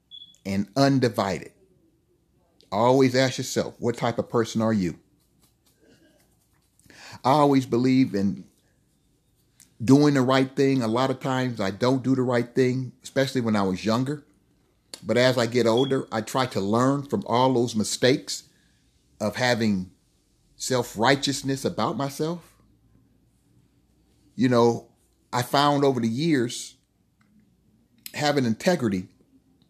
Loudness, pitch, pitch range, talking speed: -24 LUFS, 125 Hz, 110-135 Hz, 125 wpm